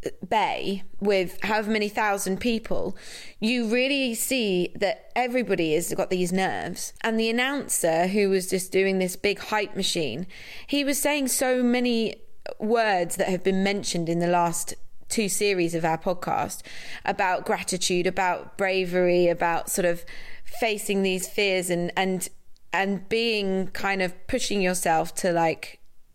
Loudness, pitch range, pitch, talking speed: -25 LUFS, 180-225 Hz, 195 Hz, 145 wpm